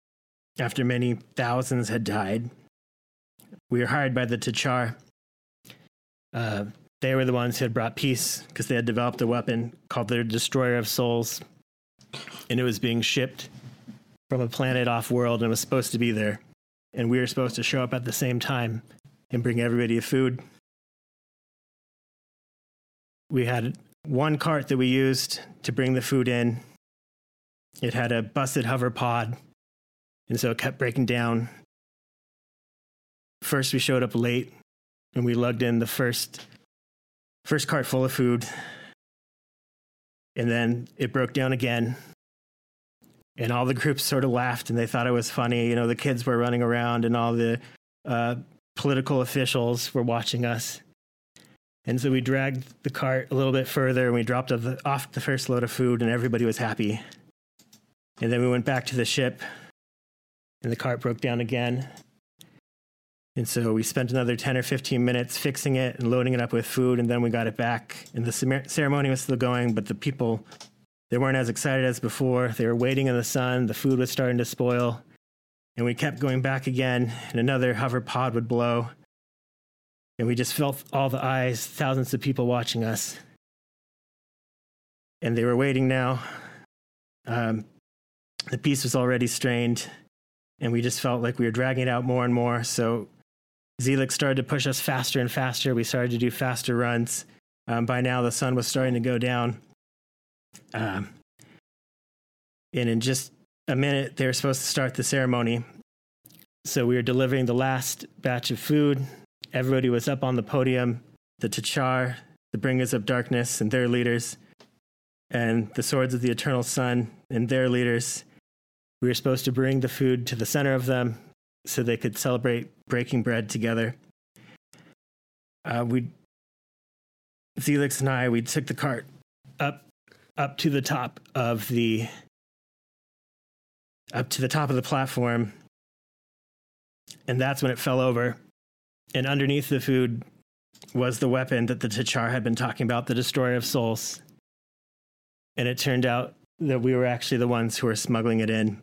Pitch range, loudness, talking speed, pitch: 115-130 Hz, -26 LUFS, 170 wpm, 125 Hz